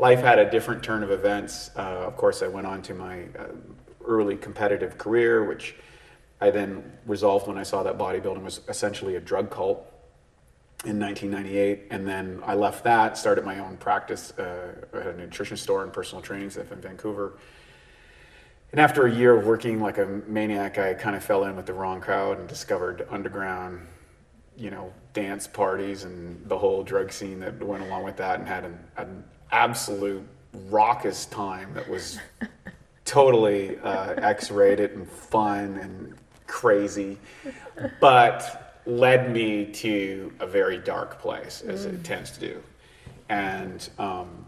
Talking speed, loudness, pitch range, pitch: 165 wpm, -25 LUFS, 100-120 Hz, 100 Hz